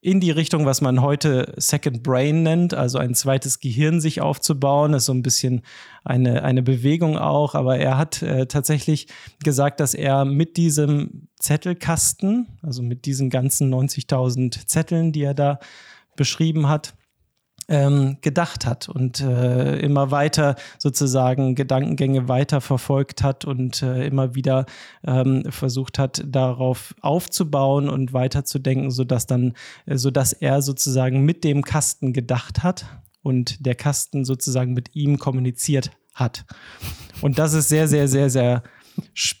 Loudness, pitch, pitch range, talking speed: -20 LUFS, 135 Hz, 130-150 Hz, 140 wpm